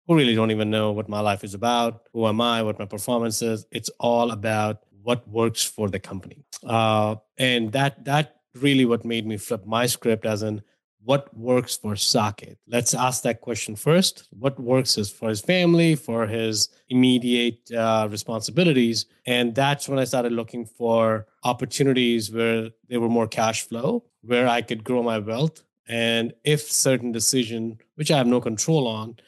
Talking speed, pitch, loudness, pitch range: 180 wpm, 115 Hz, -23 LUFS, 110-125 Hz